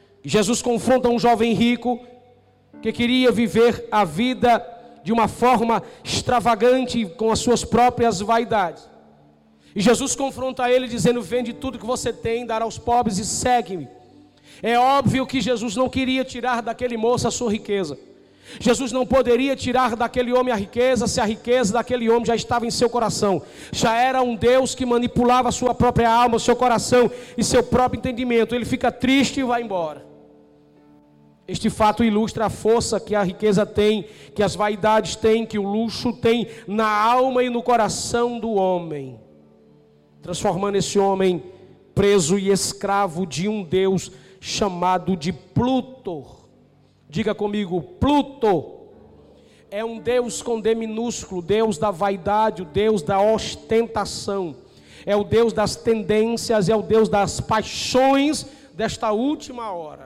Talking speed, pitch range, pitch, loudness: 150 wpm, 200-245 Hz, 225 Hz, -20 LUFS